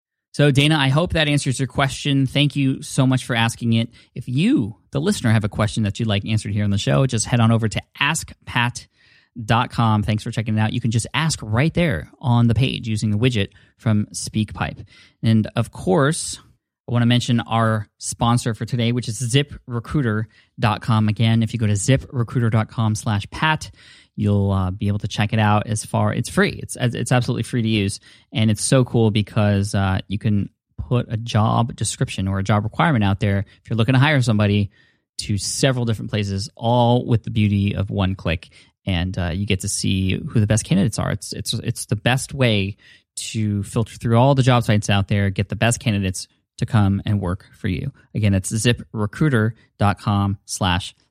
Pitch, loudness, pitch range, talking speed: 115 Hz, -20 LUFS, 105-125 Hz, 195 wpm